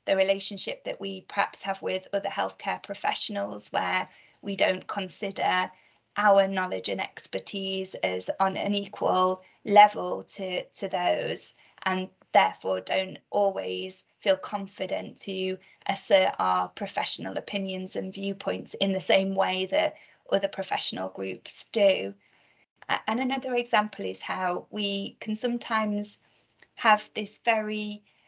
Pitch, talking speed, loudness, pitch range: 195 Hz, 125 wpm, -28 LUFS, 185-205 Hz